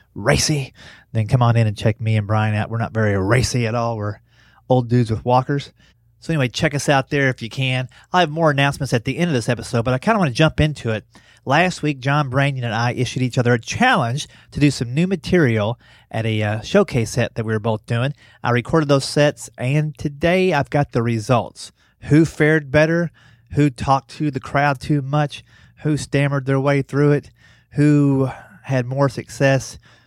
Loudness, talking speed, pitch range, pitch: -19 LUFS, 210 wpm, 115-145 Hz, 130 Hz